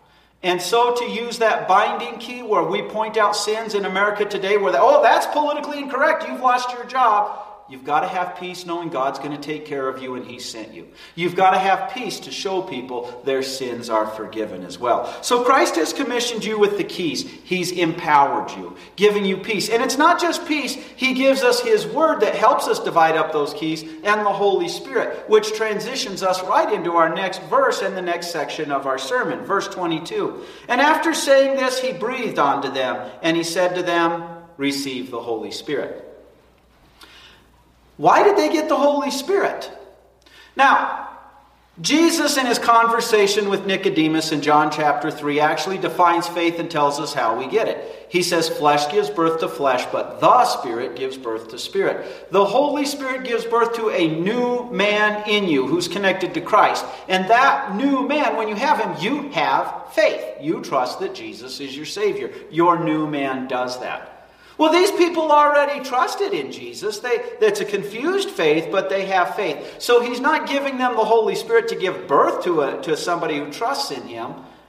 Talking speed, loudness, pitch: 190 wpm, -20 LUFS, 210 Hz